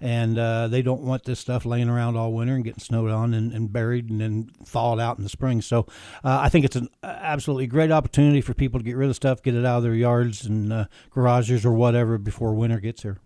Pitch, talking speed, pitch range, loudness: 120 Hz, 255 wpm, 115-130 Hz, -23 LUFS